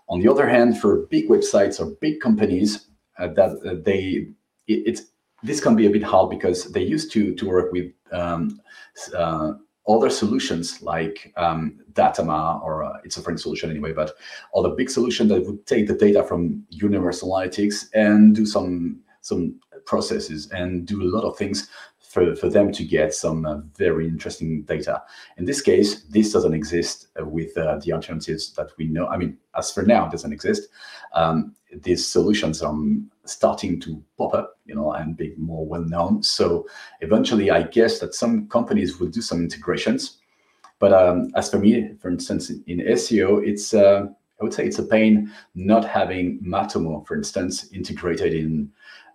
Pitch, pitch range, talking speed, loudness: 95 Hz, 80-110 Hz, 180 wpm, -21 LUFS